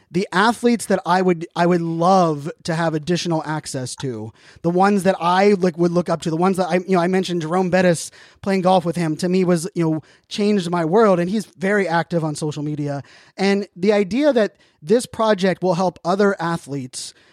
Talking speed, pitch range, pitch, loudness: 210 wpm, 165-195 Hz, 175 Hz, -19 LUFS